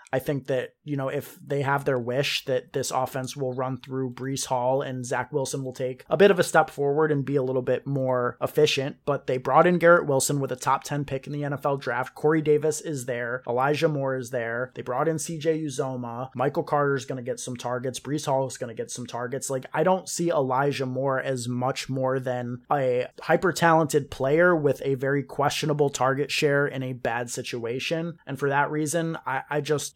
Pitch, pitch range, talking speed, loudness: 135 Hz, 130-150 Hz, 220 wpm, -25 LUFS